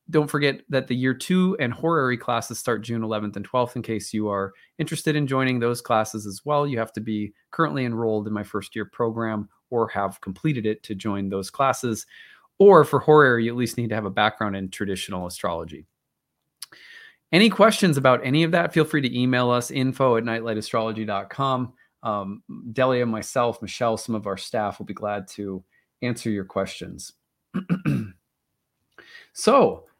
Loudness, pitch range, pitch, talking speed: -23 LUFS, 105-130 Hz, 115 Hz, 175 wpm